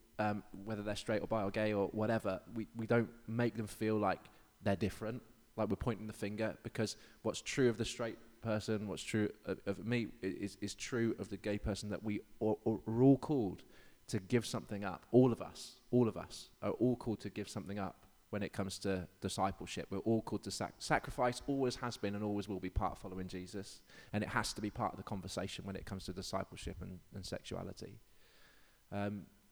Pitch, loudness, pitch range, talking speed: 105 Hz, -39 LUFS, 100-115 Hz, 215 wpm